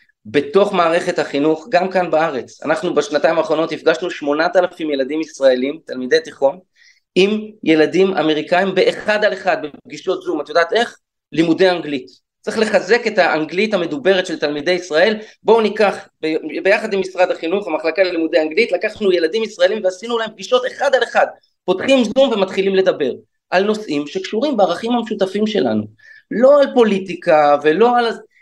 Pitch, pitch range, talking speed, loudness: 185 Hz, 155-215 Hz, 150 wpm, -17 LUFS